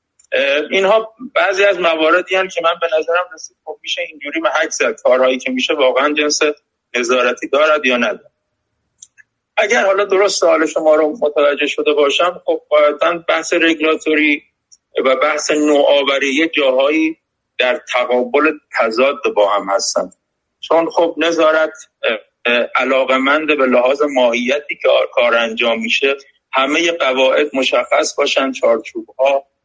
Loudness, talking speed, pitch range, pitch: -14 LUFS, 130 wpm, 130-165 Hz, 150 Hz